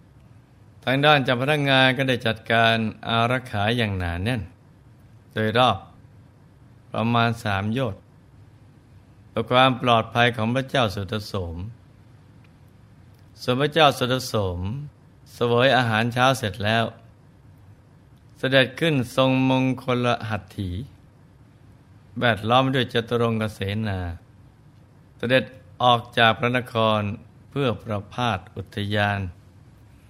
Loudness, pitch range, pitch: -22 LUFS, 110-130 Hz, 120 Hz